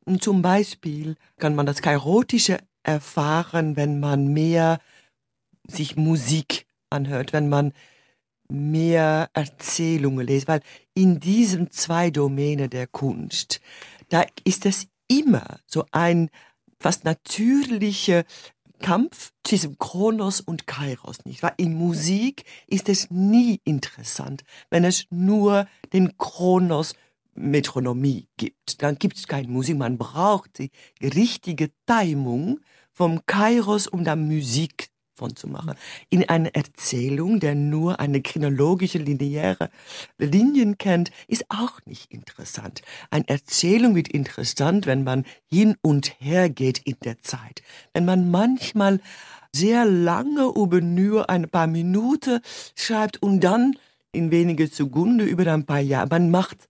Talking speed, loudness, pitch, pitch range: 125 wpm, -22 LUFS, 165 Hz, 145-195 Hz